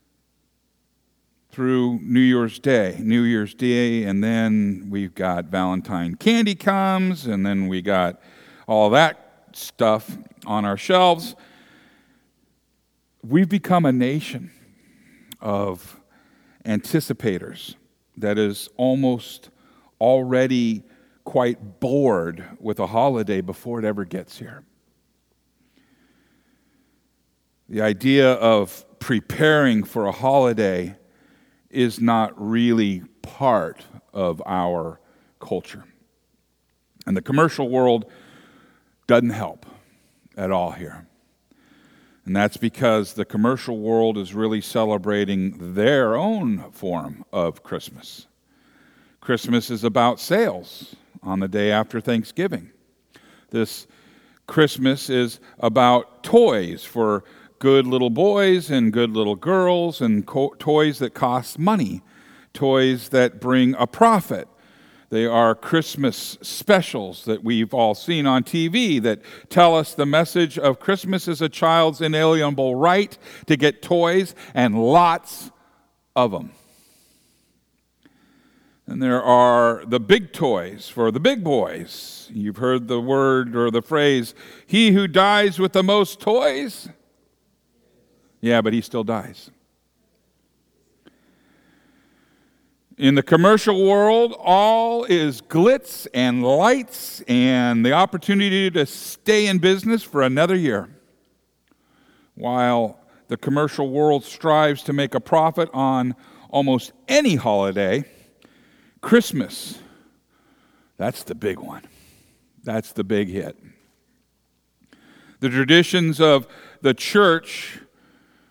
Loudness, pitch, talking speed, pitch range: -20 LUFS, 130 Hz, 110 wpm, 115-180 Hz